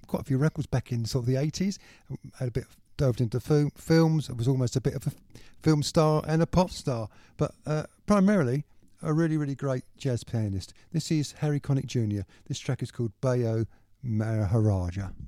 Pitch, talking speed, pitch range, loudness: 130 Hz, 200 wpm, 115-150 Hz, -28 LUFS